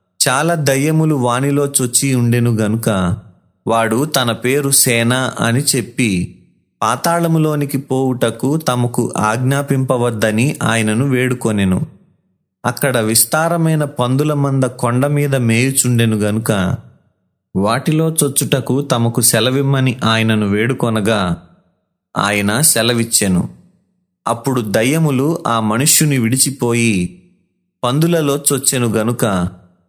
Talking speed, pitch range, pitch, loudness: 85 wpm, 110-140 Hz, 125 Hz, -15 LUFS